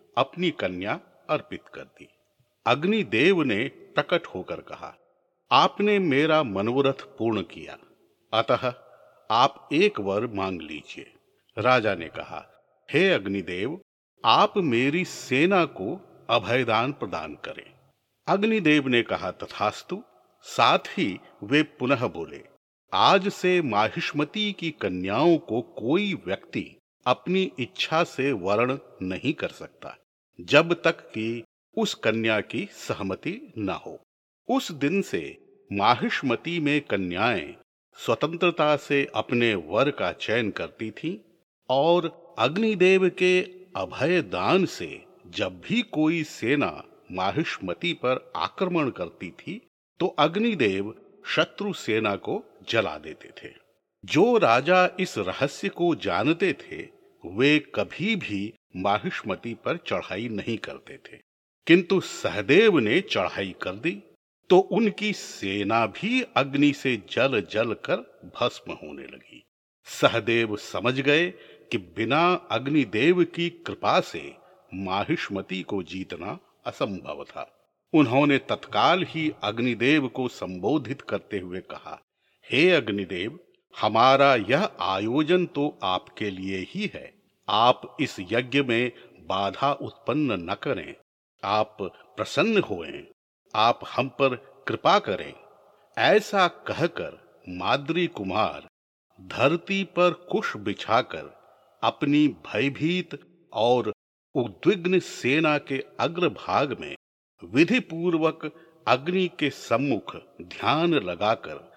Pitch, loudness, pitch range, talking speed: 145 Hz, -25 LUFS, 115-180 Hz, 115 wpm